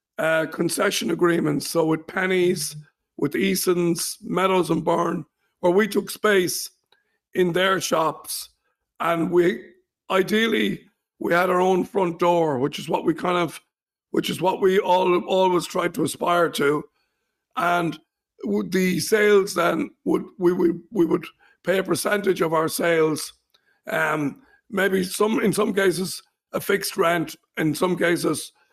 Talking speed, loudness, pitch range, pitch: 145 wpm, -22 LUFS, 170-195 Hz, 180 Hz